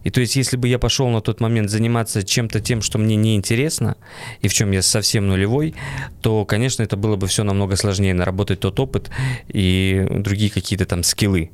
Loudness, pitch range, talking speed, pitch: -19 LUFS, 100-120 Hz, 205 wpm, 110 Hz